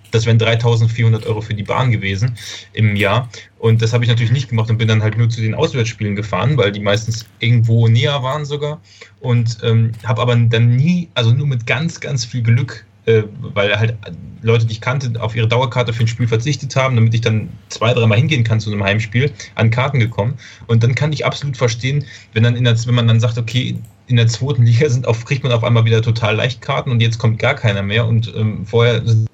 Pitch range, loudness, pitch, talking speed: 110-125 Hz, -16 LUFS, 115 Hz, 230 wpm